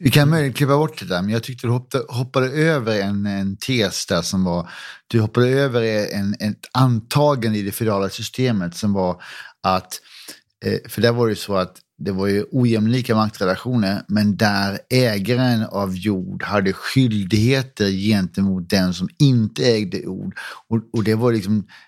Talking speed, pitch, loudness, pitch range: 175 wpm, 110 Hz, -20 LUFS, 100-125 Hz